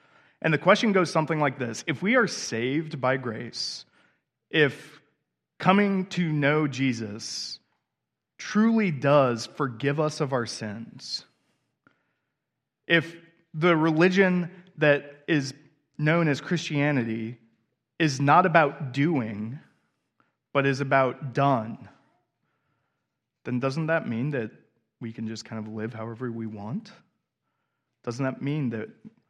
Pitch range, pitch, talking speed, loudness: 125-160 Hz, 145 Hz, 120 wpm, -25 LUFS